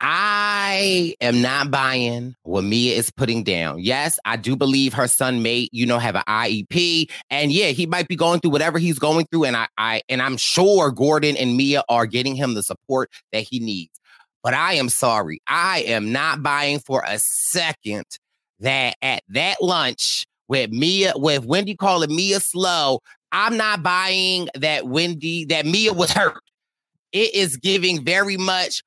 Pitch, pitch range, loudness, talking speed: 145 Hz, 125-180 Hz, -19 LUFS, 180 wpm